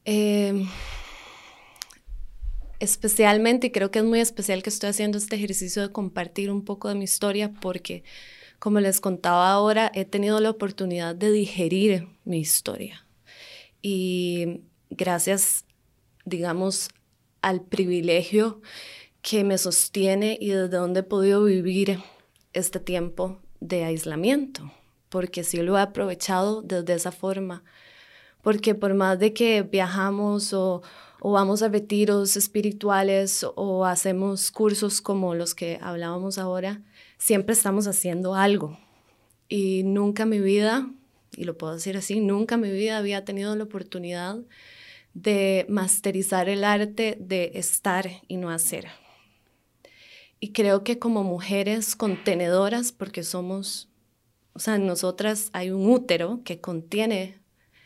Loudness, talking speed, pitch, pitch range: -24 LUFS, 135 wpm, 195 Hz, 180-210 Hz